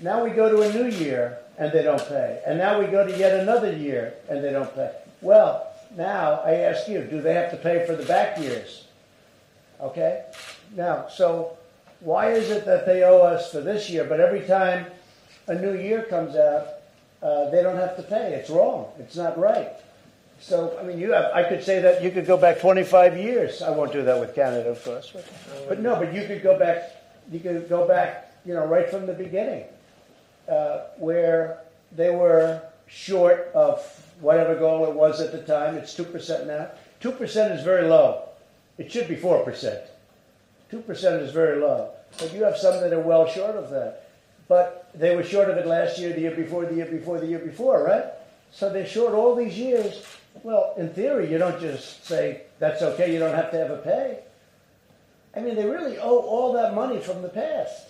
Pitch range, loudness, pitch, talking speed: 160-210 Hz, -23 LUFS, 180 Hz, 205 wpm